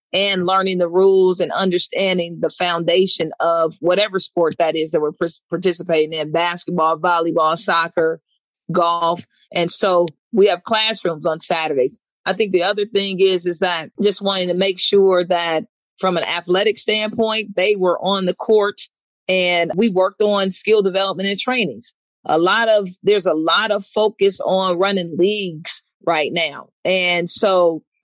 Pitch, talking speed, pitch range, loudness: 185 Hz, 160 wpm, 170-200 Hz, -18 LUFS